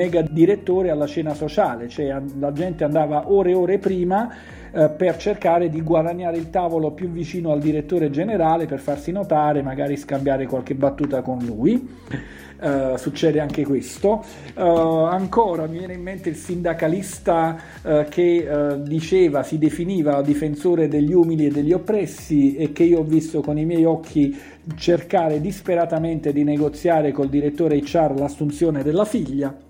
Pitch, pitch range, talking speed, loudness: 160 Hz, 145-175 Hz, 155 wpm, -20 LUFS